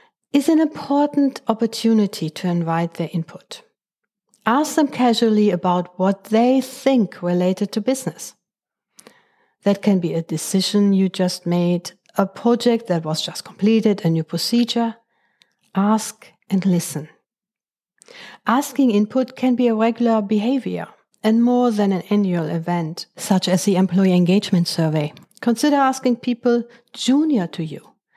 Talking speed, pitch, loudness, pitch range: 135 wpm, 215 Hz, -19 LUFS, 180-245 Hz